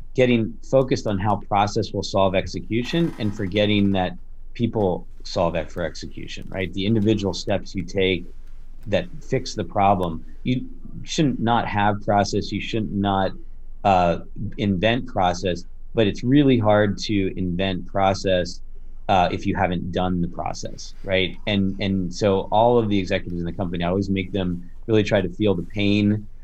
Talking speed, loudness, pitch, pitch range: 165 wpm, -22 LUFS, 100 Hz, 95-110 Hz